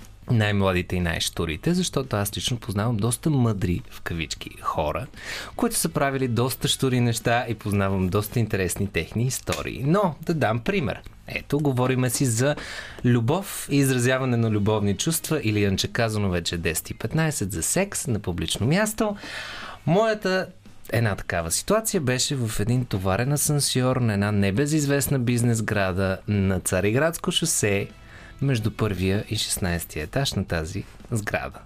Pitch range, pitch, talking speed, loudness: 100-140 Hz, 115 Hz, 145 wpm, -24 LUFS